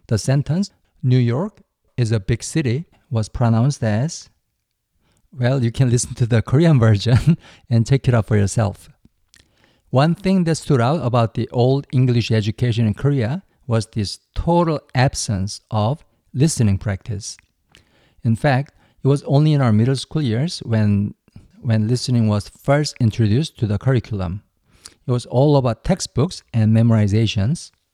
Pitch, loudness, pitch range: 120 Hz, -19 LUFS, 110-140 Hz